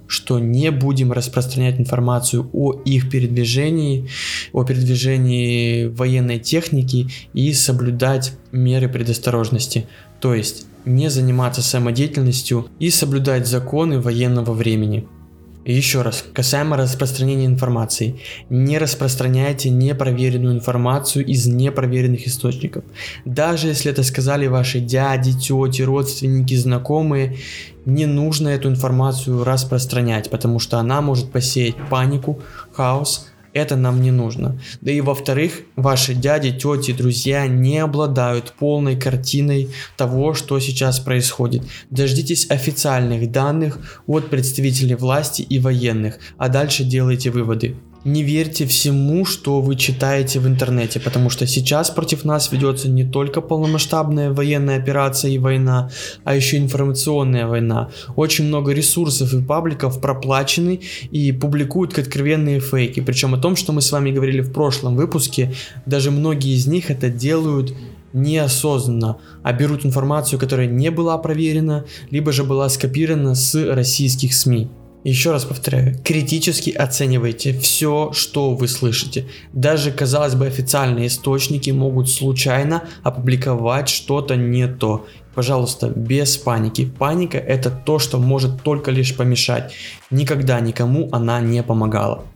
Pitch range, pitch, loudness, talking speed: 125-145 Hz, 130 Hz, -18 LUFS, 125 wpm